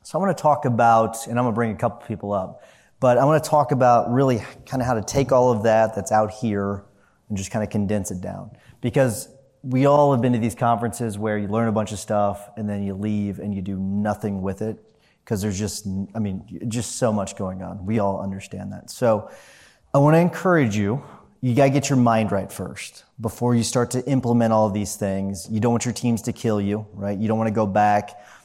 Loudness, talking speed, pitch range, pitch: -22 LUFS, 250 wpm, 100-125 Hz, 110 Hz